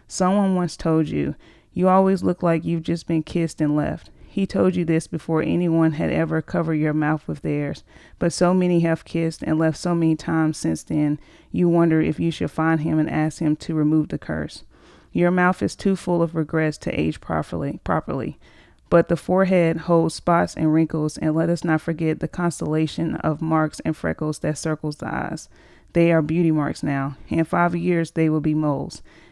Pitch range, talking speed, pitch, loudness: 155-170 Hz, 200 wpm, 160 Hz, -22 LUFS